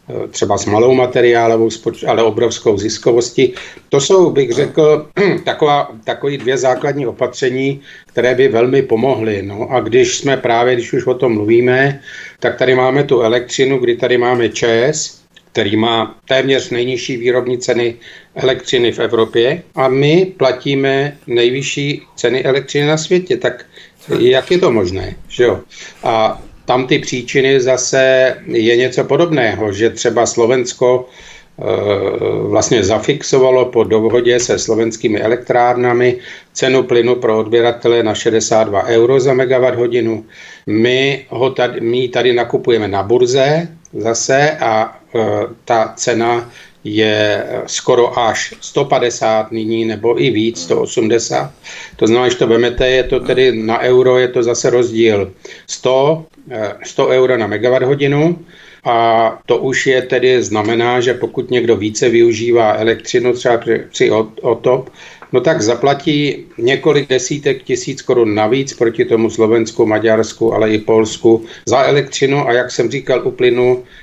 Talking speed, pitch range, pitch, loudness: 140 wpm, 115-135 Hz, 125 Hz, -13 LUFS